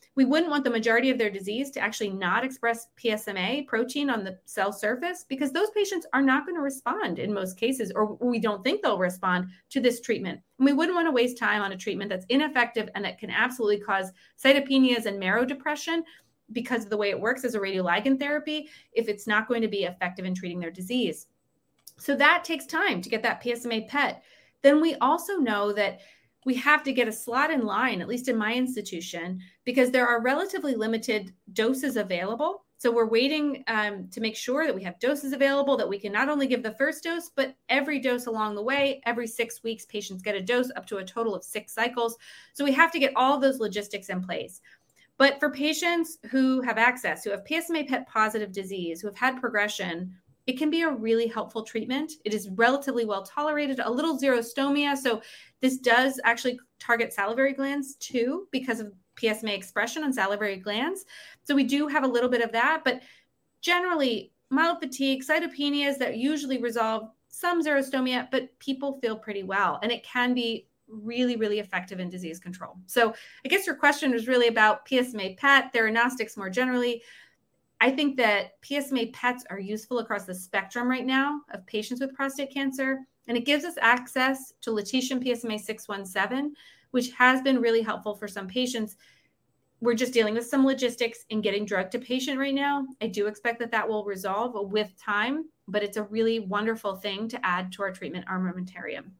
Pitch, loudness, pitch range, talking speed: 240 Hz, -27 LUFS, 210-275 Hz, 195 wpm